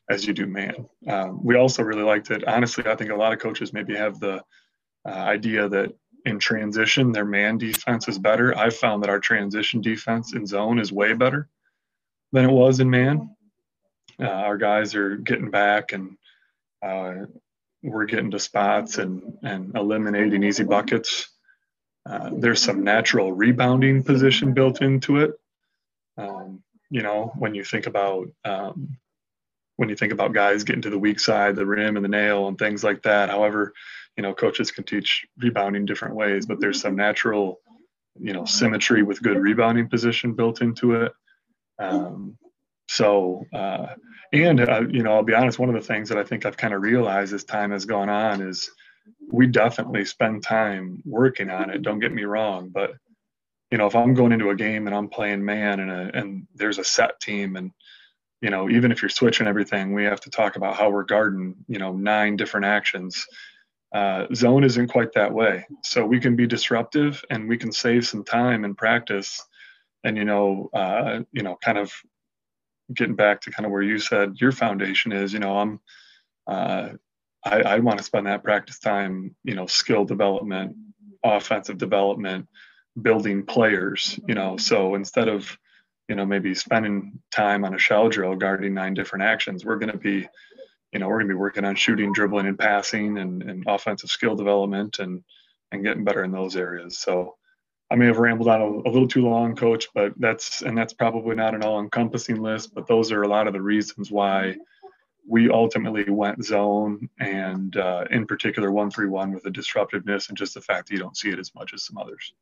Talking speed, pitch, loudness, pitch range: 195 wpm, 105 Hz, -22 LUFS, 100-120 Hz